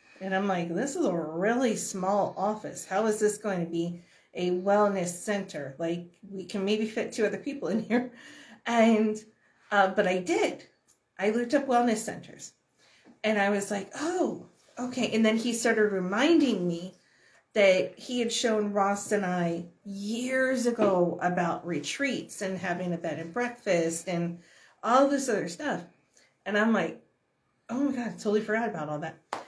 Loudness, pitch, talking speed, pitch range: -28 LUFS, 205 Hz, 170 wpm, 180-235 Hz